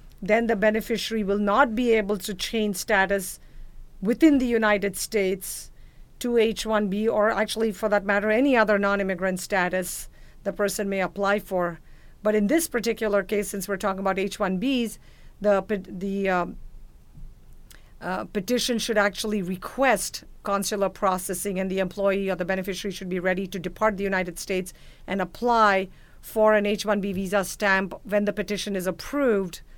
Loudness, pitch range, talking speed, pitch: -25 LUFS, 190-215 Hz, 160 wpm, 200 Hz